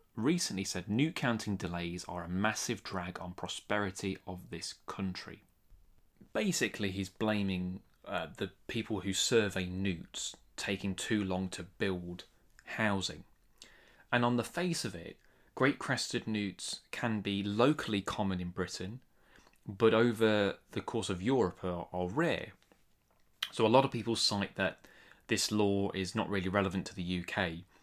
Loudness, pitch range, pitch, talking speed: -34 LUFS, 90-110 Hz, 100 Hz, 150 wpm